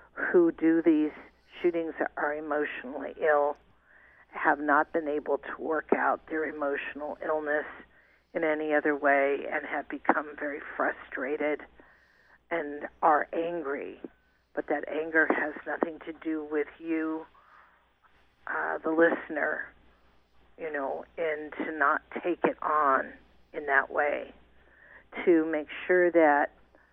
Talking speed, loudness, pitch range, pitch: 125 wpm, -29 LUFS, 145-165 Hz, 155 Hz